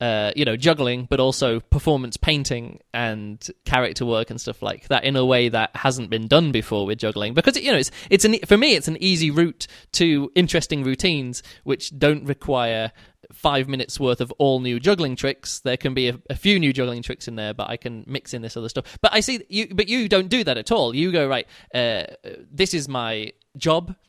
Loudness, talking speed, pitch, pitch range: -21 LUFS, 220 wpm, 135 Hz, 115-165 Hz